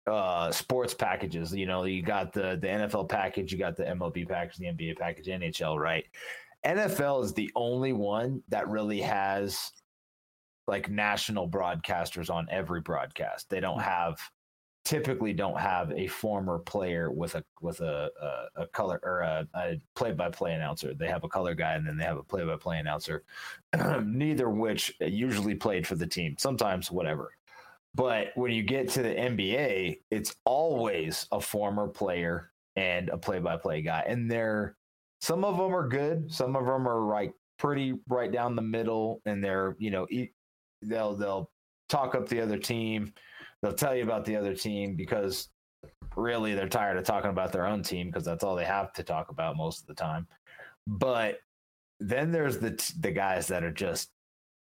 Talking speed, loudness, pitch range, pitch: 180 wpm, -31 LUFS, 95-125 Hz, 105 Hz